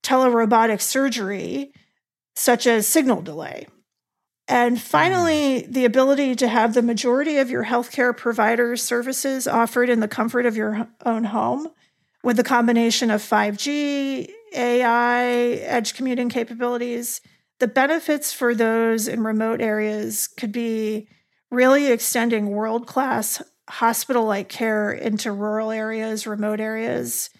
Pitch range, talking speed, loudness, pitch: 220-255 Hz, 125 wpm, -21 LUFS, 240 Hz